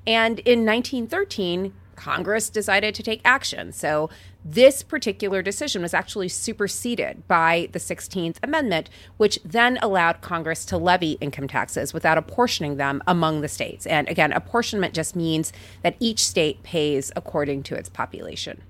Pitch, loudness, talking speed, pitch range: 180 Hz, -22 LUFS, 150 wpm, 160-225 Hz